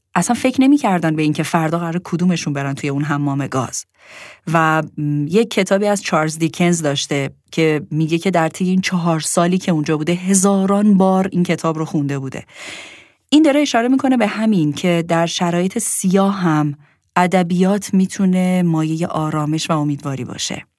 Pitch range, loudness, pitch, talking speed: 155-190 Hz, -17 LUFS, 170 Hz, 160 wpm